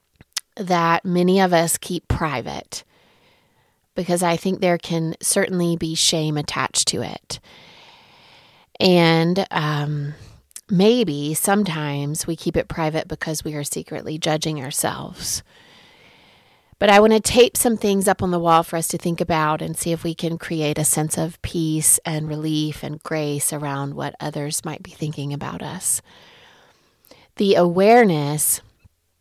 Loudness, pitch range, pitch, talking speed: -20 LUFS, 150-180 Hz, 165 Hz, 145 wpm